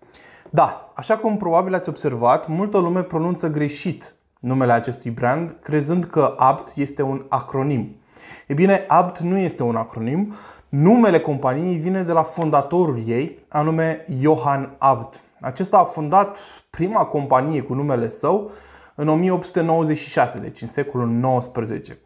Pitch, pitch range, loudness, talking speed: 155 Hz, 130-175 Hz, -20 LUFS, 135 wpm